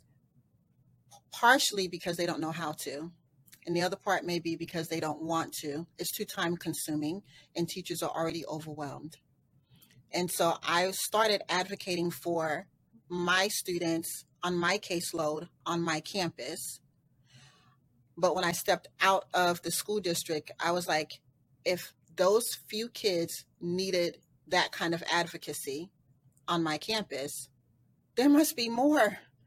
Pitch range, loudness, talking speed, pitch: 150-180 Hz, -31 LUFS, 140 wpm, 170 Hz